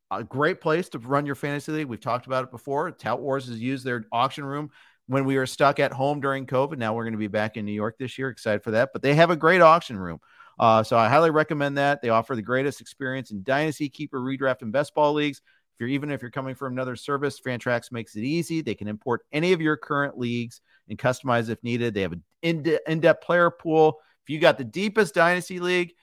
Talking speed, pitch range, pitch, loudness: 245 wpm, 120-150 Hz, 135 Hz, -24 LUFS